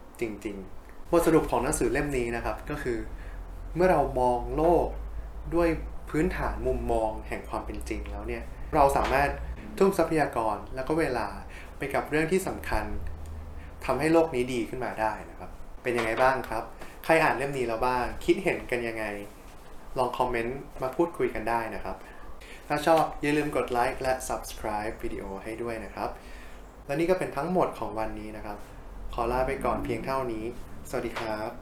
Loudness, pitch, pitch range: -28 LUFS, 115 Hz, 100-140 Hz